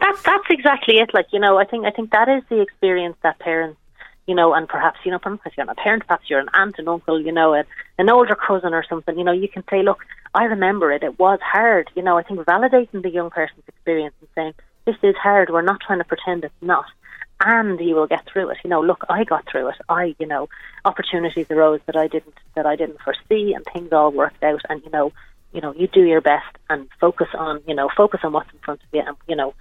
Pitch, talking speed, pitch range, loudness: 170 Hz, 260 wpm, 155-200 Hz, -19 LUFS